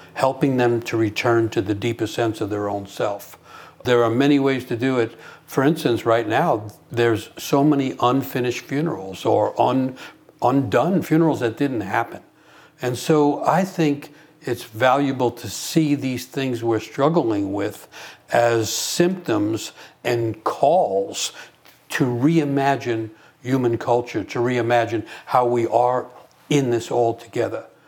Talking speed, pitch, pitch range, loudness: 140 wpm, 120 Hz, 115-140 Hz, -21 LUFS